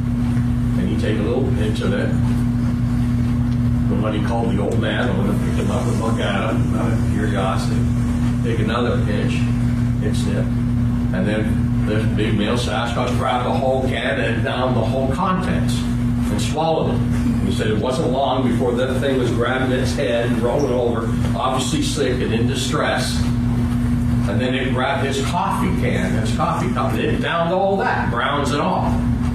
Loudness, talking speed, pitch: -19 LUFS, 175 wpm, 120 Hz